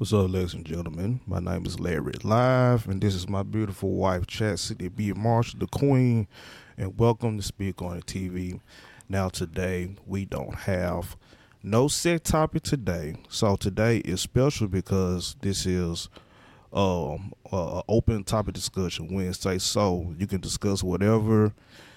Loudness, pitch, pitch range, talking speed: -27 LUFS, 100 Hz, 90-110 Hz, 155 wpm